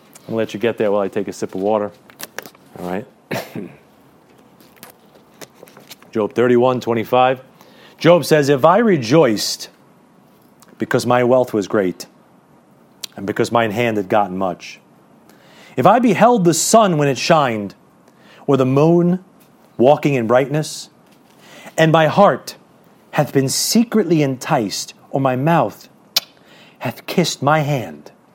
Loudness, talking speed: -16 LUFS, 135 wpm